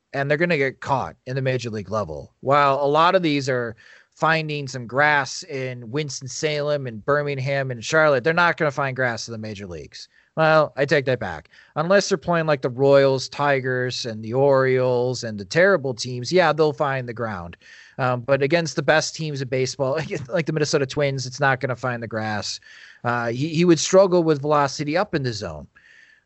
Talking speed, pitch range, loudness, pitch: 205 wpm, 125-155 Hz, -21 LUFS, 140 Hz